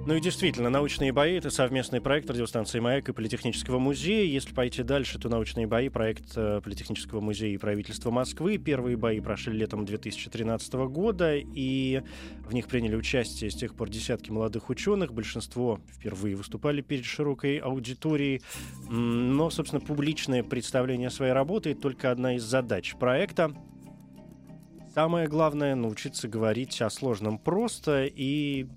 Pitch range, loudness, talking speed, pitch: 115-145 Hz, -29 LUFS, 140 wpm, 125 Hz